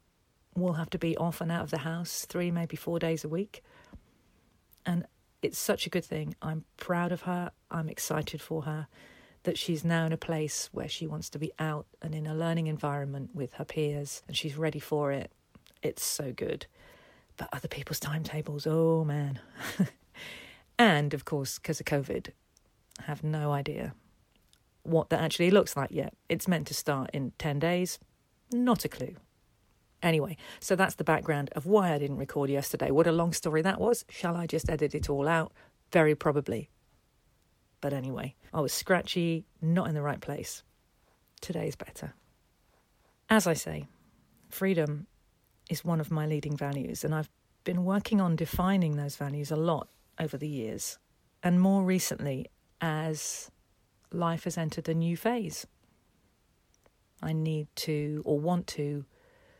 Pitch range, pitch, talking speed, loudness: 145-170 Hz, 160 Hz, 170 wpm, -31 LUFS